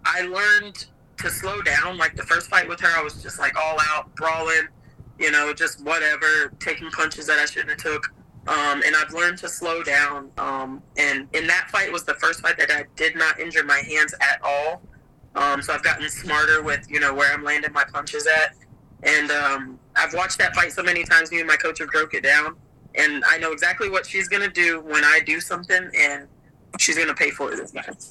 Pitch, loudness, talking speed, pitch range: 150 Hz, -20 LUFS, 220 wpm, 140-160 Hz